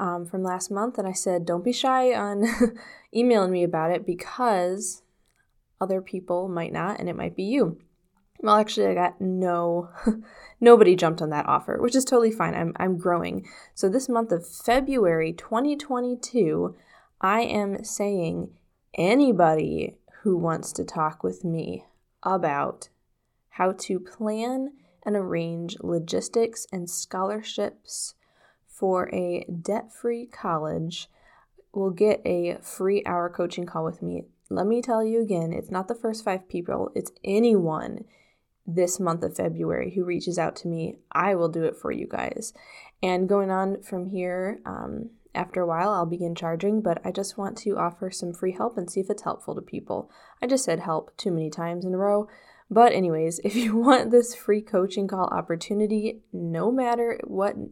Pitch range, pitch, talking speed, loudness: 175-225 Hz, 190 Hz, 165 wpm, -25 LUFS